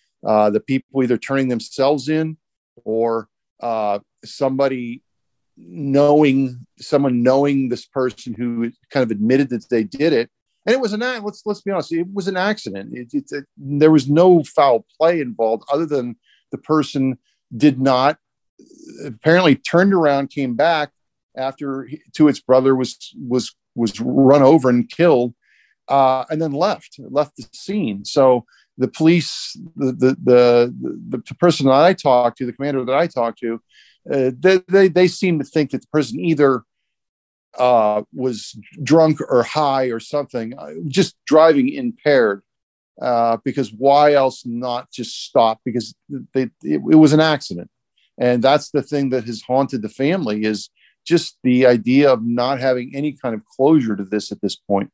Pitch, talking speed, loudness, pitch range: 135 Hz, 170 wpm, -17 LUFS, 120-150 Hz